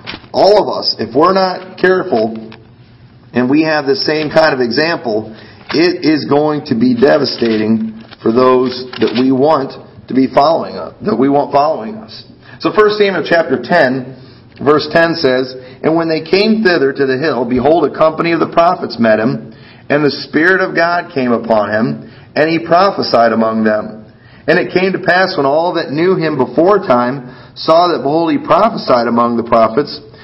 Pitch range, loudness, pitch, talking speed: 125-170 Hz, -12 LUFS, 140 Hz, 180 wpm